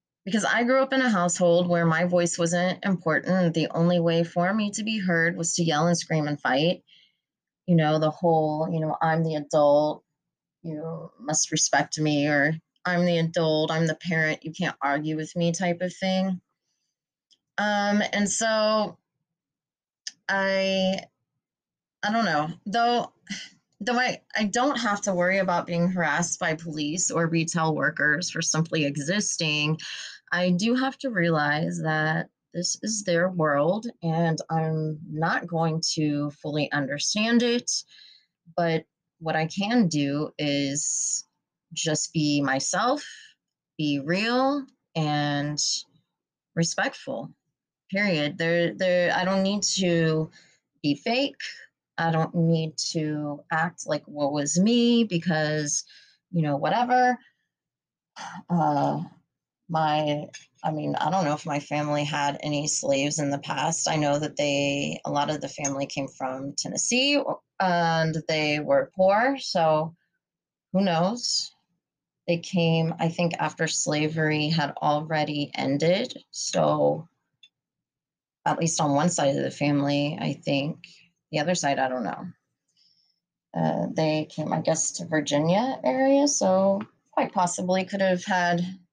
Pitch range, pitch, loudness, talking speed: 150-190 Hz, 165 Hz, -25 LUFS, 140 wpm